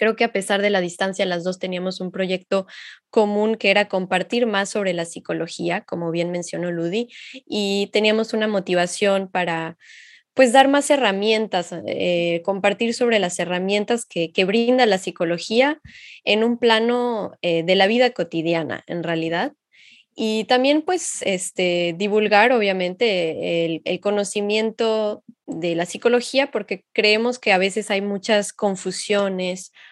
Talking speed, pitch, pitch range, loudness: 145 wpm, 200 Hz, 180-225 Hz, -20 LUFS